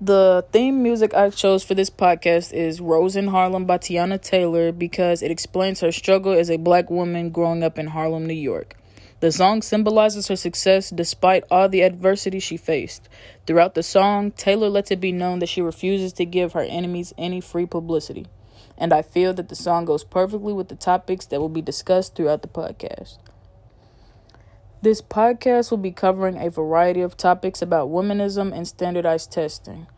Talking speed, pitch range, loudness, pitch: 180 wpm, 165-190 Hz, -20 LUFS, 175 Hz